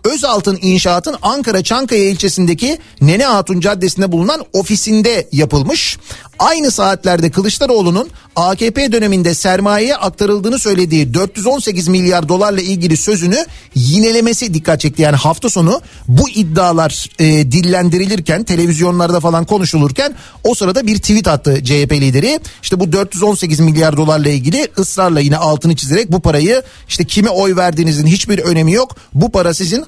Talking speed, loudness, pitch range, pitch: 135 wpm, -12 LUFS, 165-210 Hz, 185 Hz